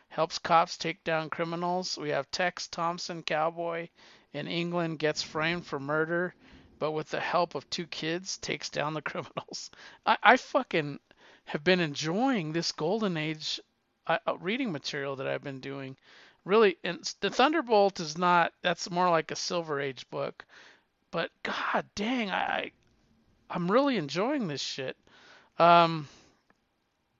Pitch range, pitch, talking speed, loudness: 155-185 Hz, 170 Hz, 145 wpm, -29 LUFS